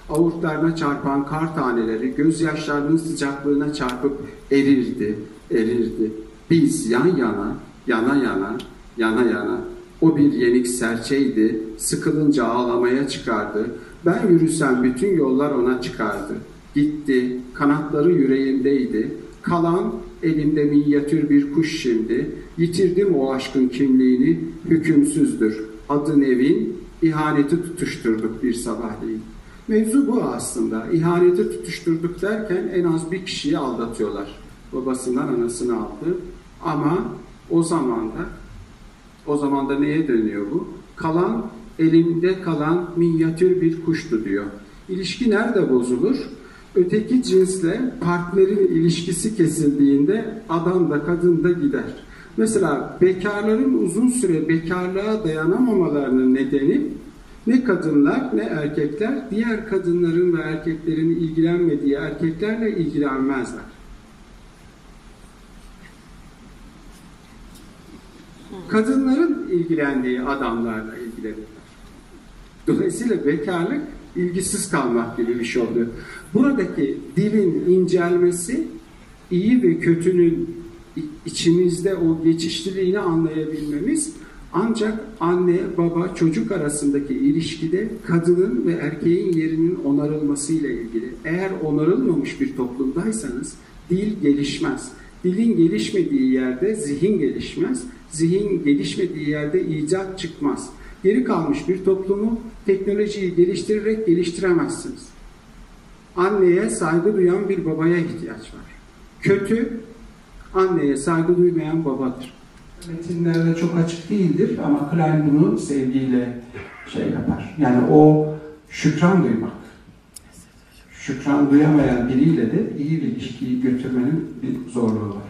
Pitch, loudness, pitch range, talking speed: 165 Hz, -20 LUFS, 140-185 Hz, 100 wpm